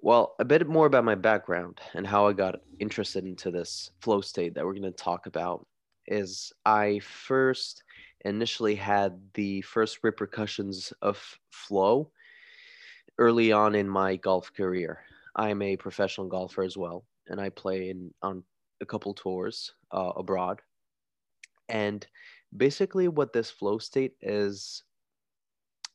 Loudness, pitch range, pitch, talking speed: -28 LUFS, 95-110 Hz, 100 Hz, 145 wpm